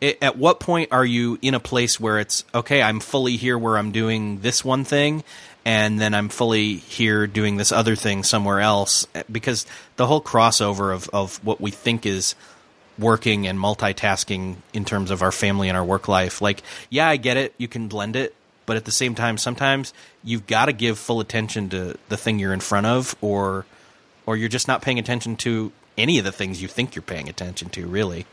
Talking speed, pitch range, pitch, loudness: 210 wpm, 100-120 Hz, 110 Hz, -21 LUFS